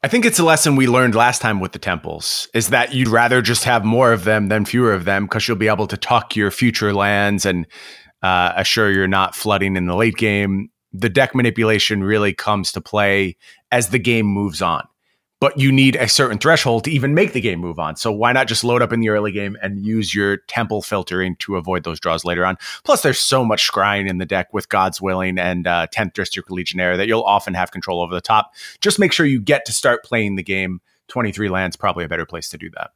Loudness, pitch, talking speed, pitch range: -17 LUFS, 105 Hz, 240 wpm, 95-120 Hz